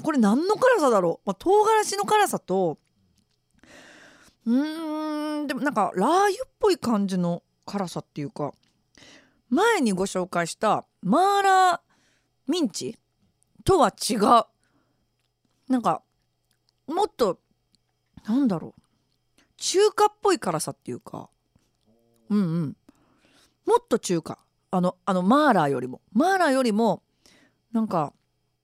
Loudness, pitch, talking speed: -24 LUFS, 245 Hz, 235 characters per minute